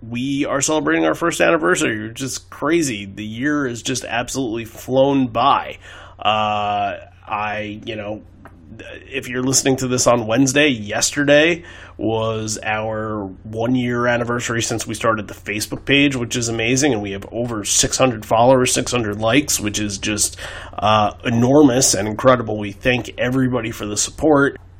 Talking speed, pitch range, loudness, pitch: 150 wpm, 105-130 Hz, -18 LUFS, 115 Hz